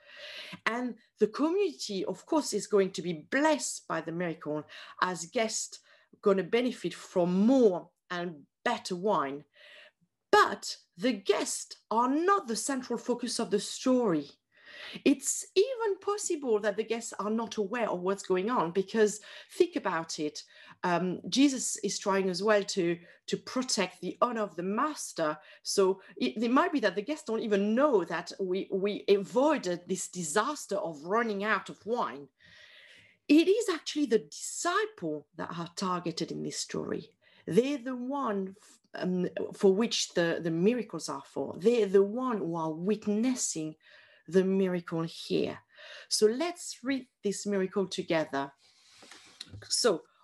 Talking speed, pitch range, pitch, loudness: 150 wpm, 180-250 Hz, 210 Hz, -30 LUFS